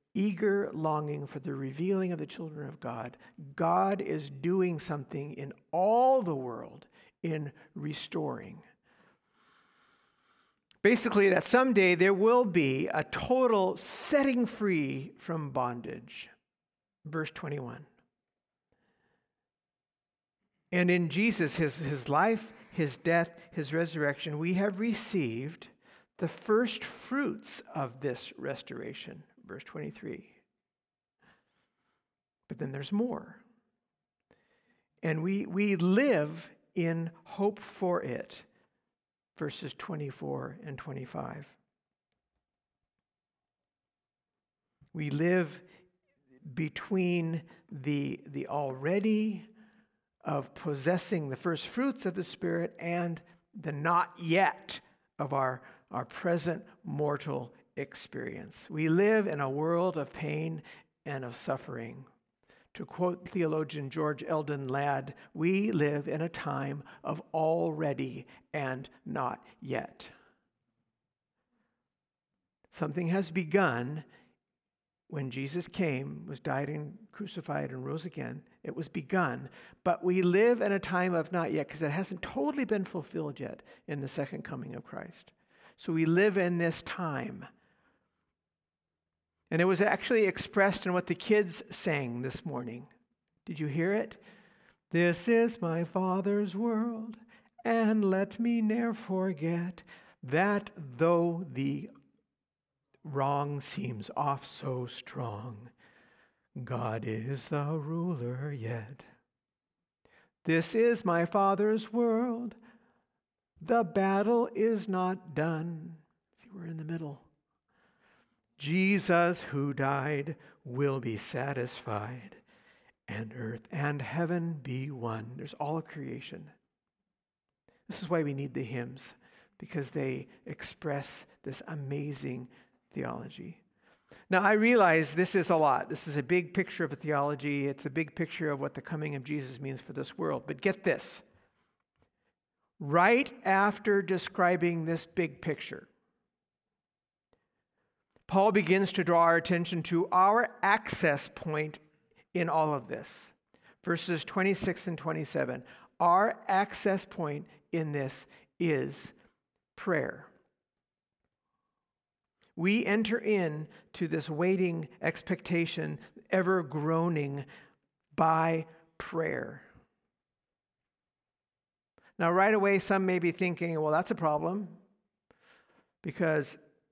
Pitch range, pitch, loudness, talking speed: 145-195 Hz, 170 Hz, -31 LUFS, 115 wpm